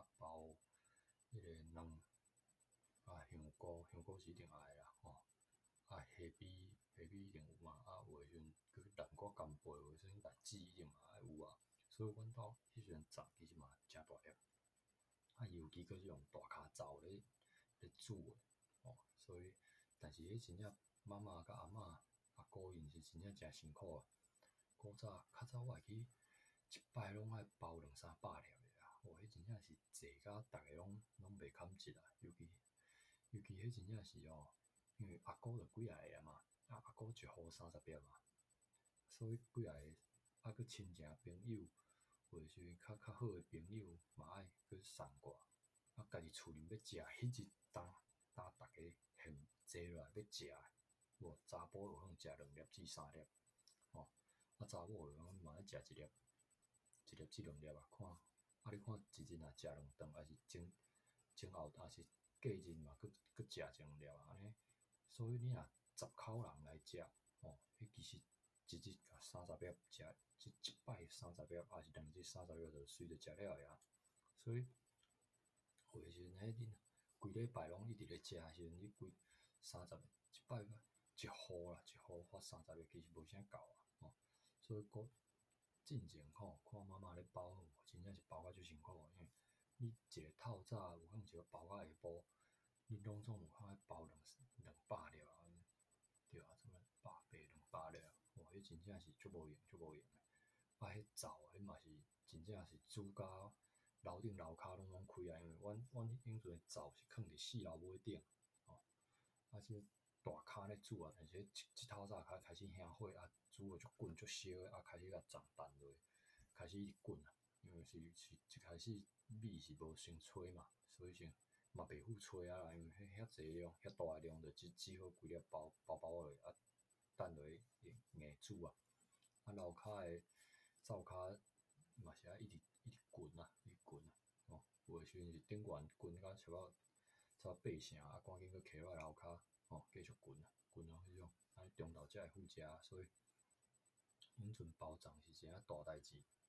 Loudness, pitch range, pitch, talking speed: -58 LUFS, 80-110 Hz, 95 Hz, 240 characters per minute